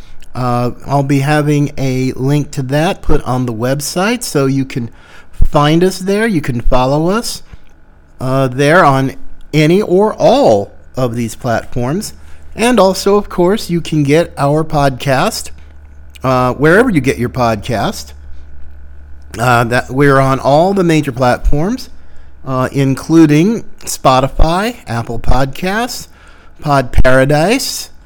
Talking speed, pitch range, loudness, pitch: 135 wpm, 115-160 Hz, -13 LUFS, 135 Hz